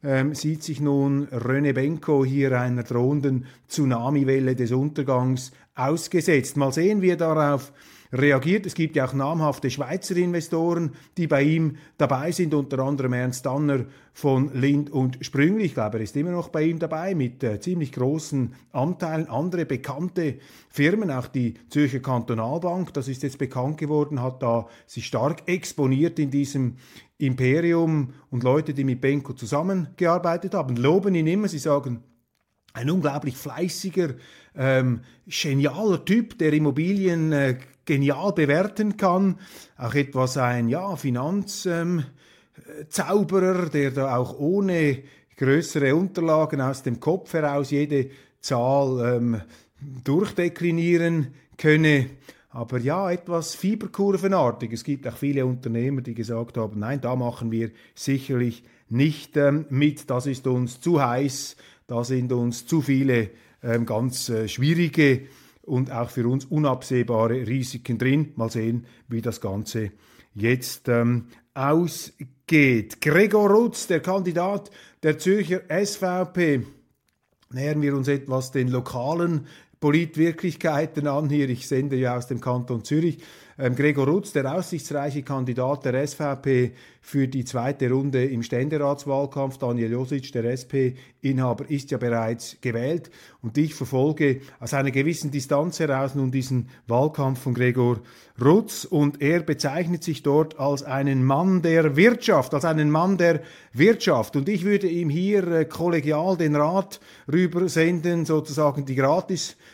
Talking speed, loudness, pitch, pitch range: 135 wpm, -24 LUFS, 140 Hz, 130-165 Hz